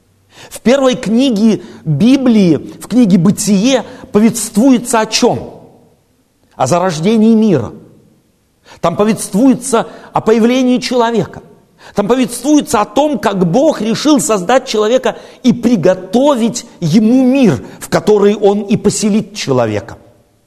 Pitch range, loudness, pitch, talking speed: 185-245 Hz, -12 LUFS, 220 Hz, 110 wpm